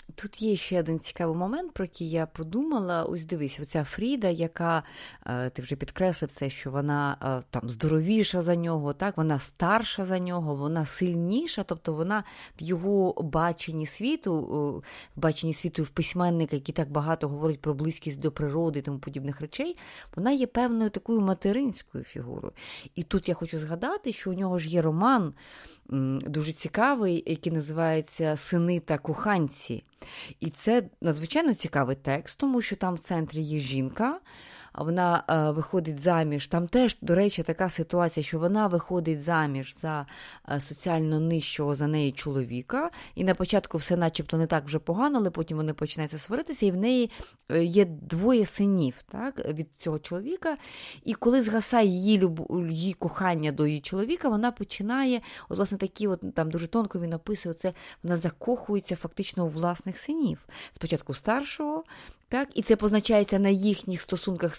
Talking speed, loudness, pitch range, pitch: 160 wpm, -28 LUFS, 155-205 Hz, 170 Hz